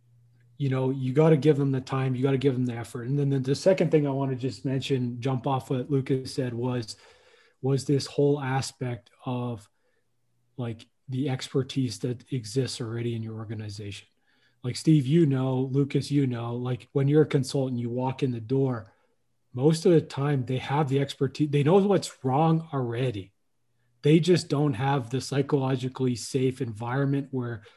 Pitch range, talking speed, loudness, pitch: 120-140 Hz, 185 wpm, -27 LUFS, 135 Hz